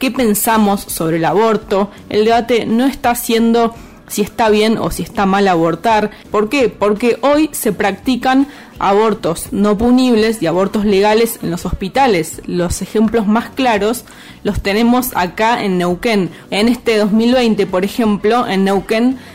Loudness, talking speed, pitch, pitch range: -14 LUFS, 150 wpm, 220 Hz, 200-235 Hz